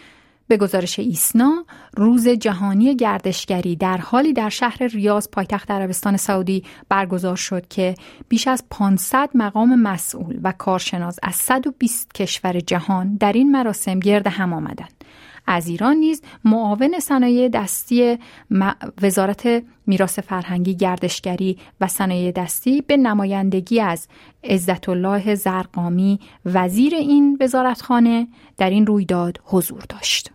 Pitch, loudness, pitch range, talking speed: 205 Hz, -19 LUFS, 185-245 Hz, 120 wpm